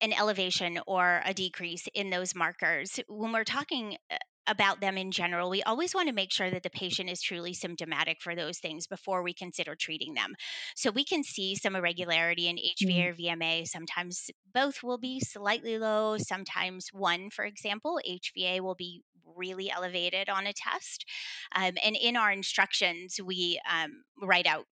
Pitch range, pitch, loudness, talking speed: 180-215 Hz, 190 Hz, -31 LUFS, 175 wpm